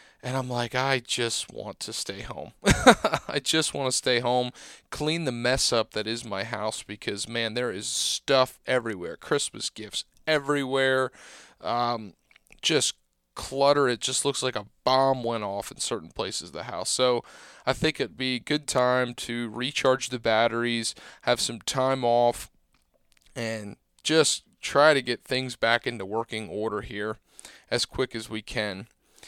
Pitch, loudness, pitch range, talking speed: 125 Hz, -26 LUFS, 115-130 Hz, 165 wpm